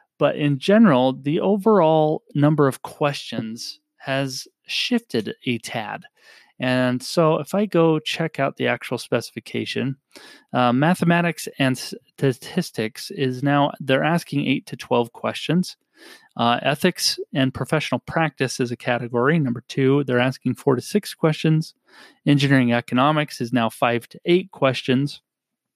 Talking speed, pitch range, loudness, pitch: 135 wpm, 130-160 Hz, -21 LUFS, 140 Hz